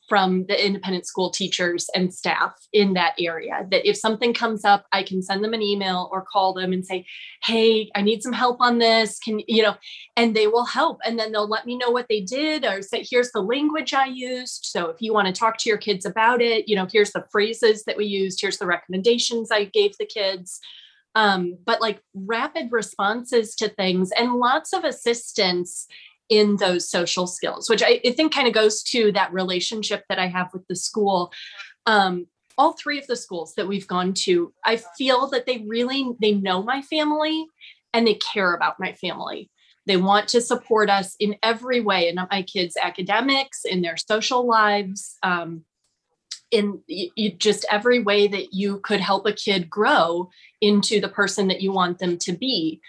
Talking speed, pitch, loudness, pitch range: 200 wpm, 210 Hz, -22 LUFS, 190-235 Hz